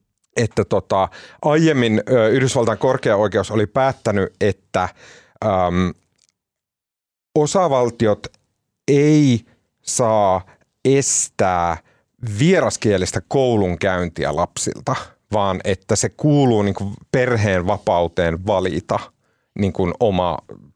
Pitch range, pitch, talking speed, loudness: 95-130 Hz, 110 Hz, 80 wpm, -18 LUFS